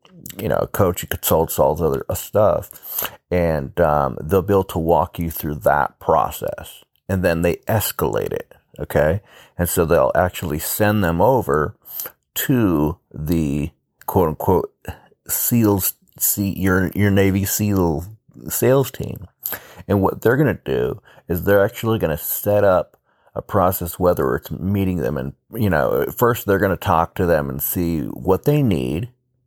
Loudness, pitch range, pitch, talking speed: -19 LUFS, 80-105 Hz, 95 Hz, 165 wpm